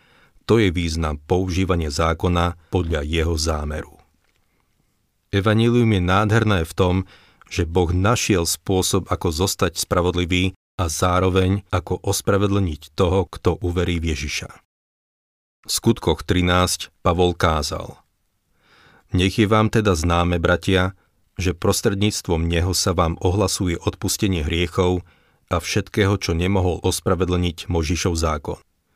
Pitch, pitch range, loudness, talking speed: 90 Hz, 85-95 Hz, -20 LUFS, 115 wpm